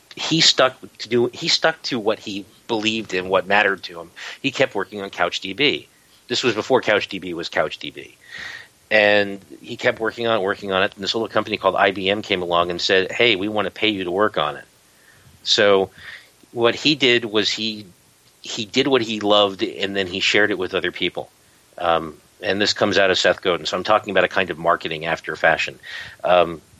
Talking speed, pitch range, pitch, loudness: 210 wpm, 95-115 Hz, 105 Hz, -19 LUFS